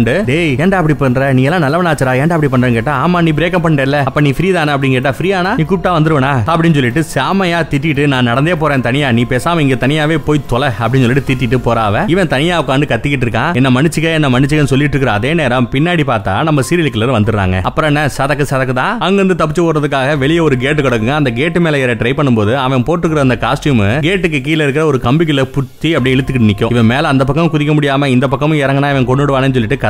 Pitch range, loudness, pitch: 130-160 Hz, -12 LUFS, 140 Hz